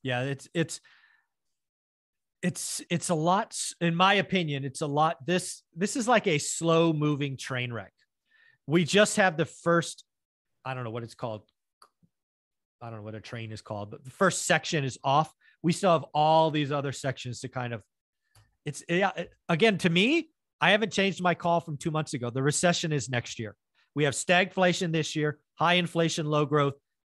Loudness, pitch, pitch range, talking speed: -27 LUFS, 160 Hz, 135-175 Hz, 190 wpm